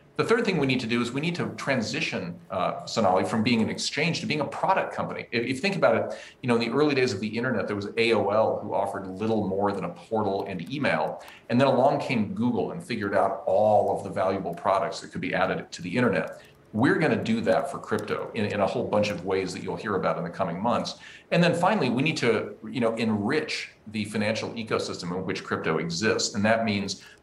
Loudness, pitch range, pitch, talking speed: -26 LUFS, 95-120 Hz, 105 Hz, 240 wpm